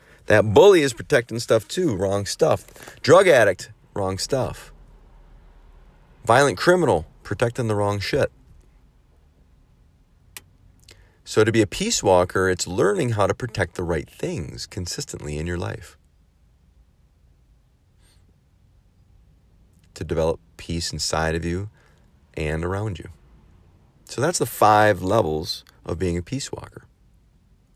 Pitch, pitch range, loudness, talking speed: 90 Hz, 80-105 Hz, -21 LUFS, 120 wpm